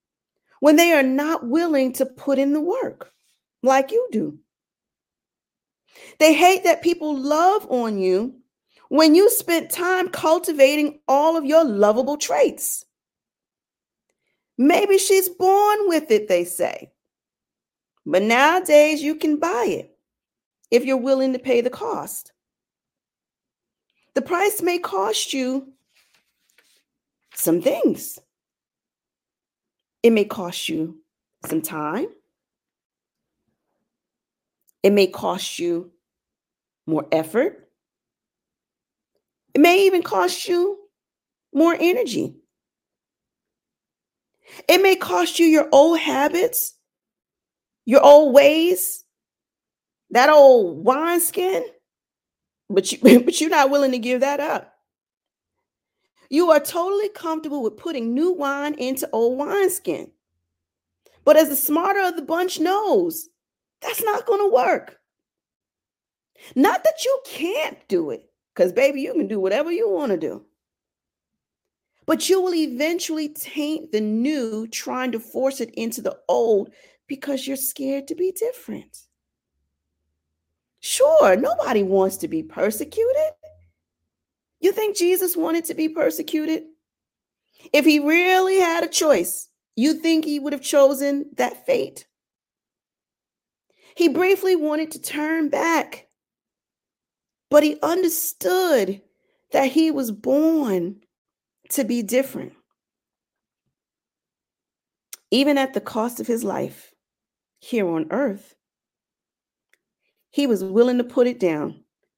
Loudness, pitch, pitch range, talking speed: -19 LUFS, 300 Hz, 245-345 Hz, 120 wpm